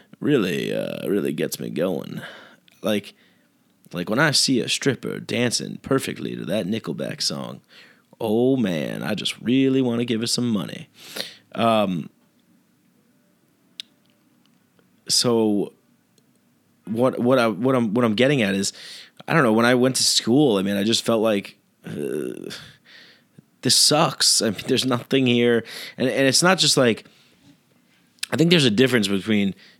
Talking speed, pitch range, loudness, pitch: 155 wpm, 110-130 Hz, -21 LUFS, 120 Hz